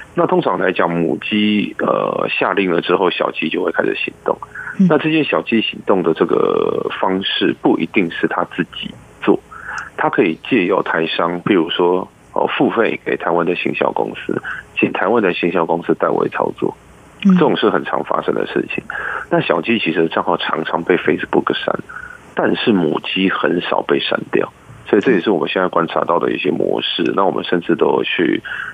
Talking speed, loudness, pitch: 280 characters per minute, -17 LUFS, 390 Hz